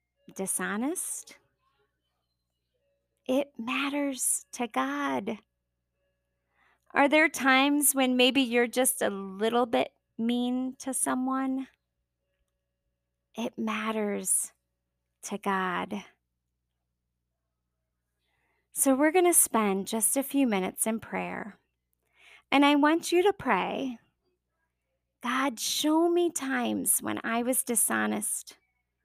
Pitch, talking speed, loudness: 220 Hz, 95 wpm, -27 LUFS